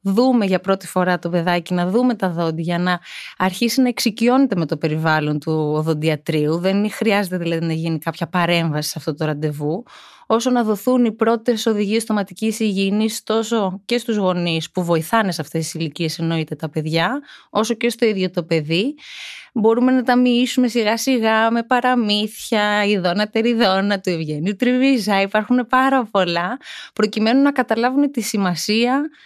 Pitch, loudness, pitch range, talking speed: 205 Hz, -19 LUFS, 170-235 Hz, 160 wpm